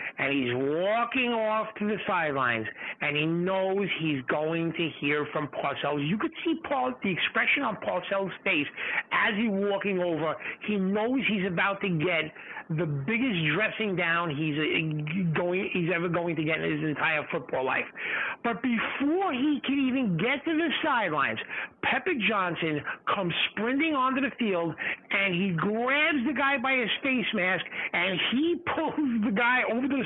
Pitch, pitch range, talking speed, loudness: 205 Hz, 170-260 Hz, 170 wpm, -27 LUFS